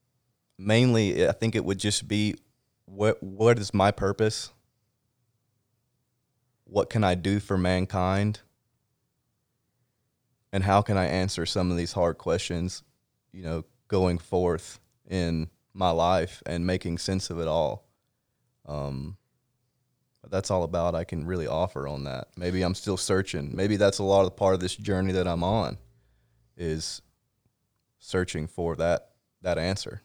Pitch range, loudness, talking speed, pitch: 90-115 Hz, -27 LUFS, 150 wpm, 95 Hz